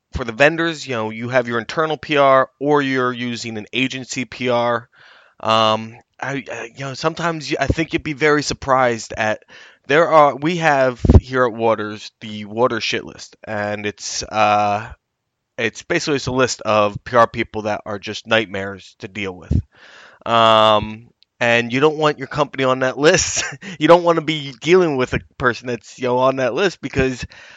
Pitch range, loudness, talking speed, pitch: 110-145 Hz, -18 LUFS, 185 wpm, 125 Hz